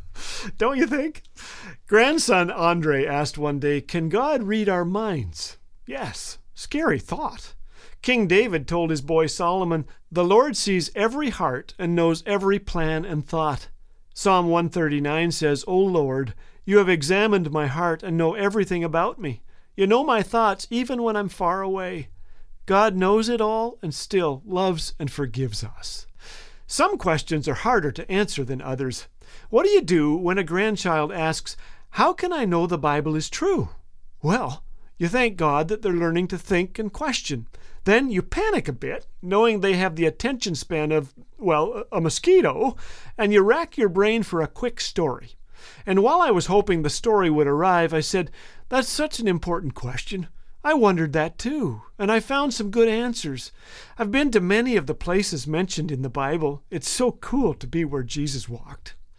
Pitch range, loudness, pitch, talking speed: 150-215 Hz, -23 LUFS, 175 Hz, 175 wpm